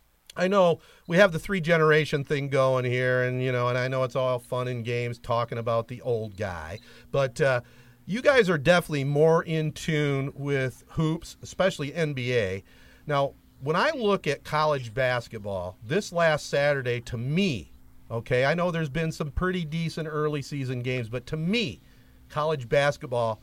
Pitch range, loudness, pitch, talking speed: 120-160 Hz, -26 LUFS, 140 Hz, 170 wpm